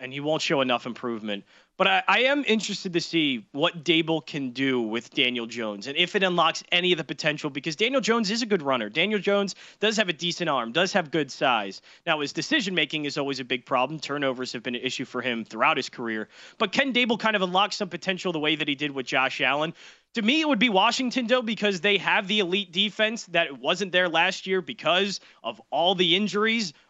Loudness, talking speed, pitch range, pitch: -24 LUFS, 230 wpm, 140-205 Hz, 175 Hz